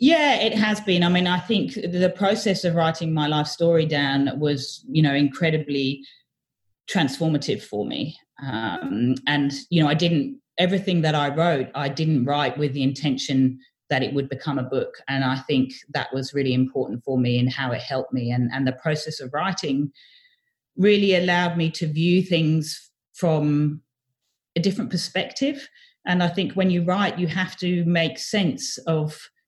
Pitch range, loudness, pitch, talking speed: 135-180 Hz, -23 LUFS, 155 Hz, 175 wpm